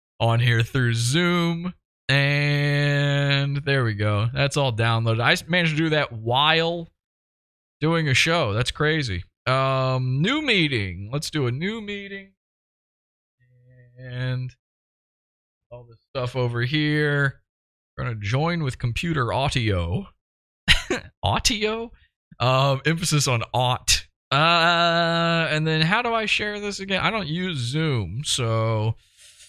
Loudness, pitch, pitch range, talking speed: -22 LUFS, 135 Hz, 120-165 Hz, 125 wpm